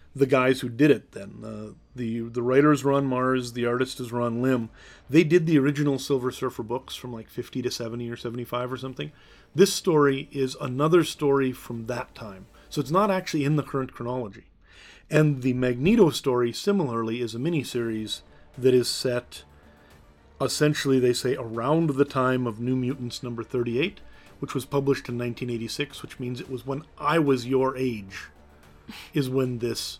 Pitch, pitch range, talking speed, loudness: 125 Hz, 120-140 Hz, 185 wpm, -25 LUFS